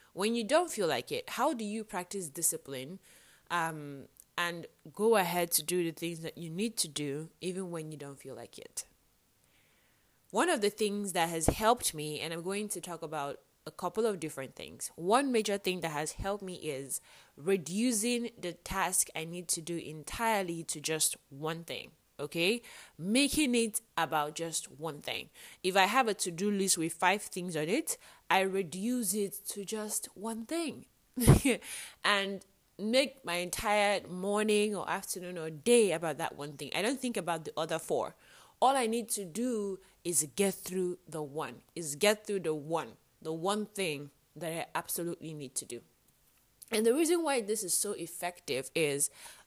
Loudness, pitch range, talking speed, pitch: -33 LUFS, 160-210 Hz, 180 wpm, 180 Hz